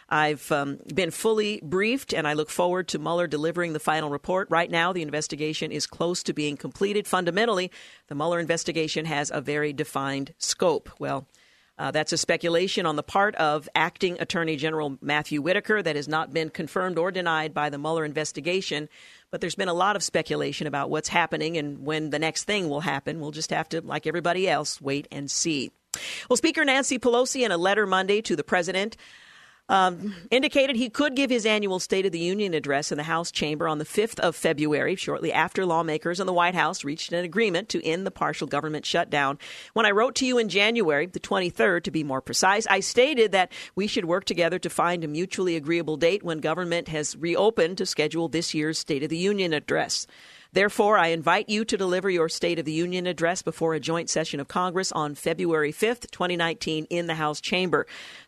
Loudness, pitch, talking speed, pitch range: -25 LUFS, 170 Hz, 205 wpm, 155-190 Hz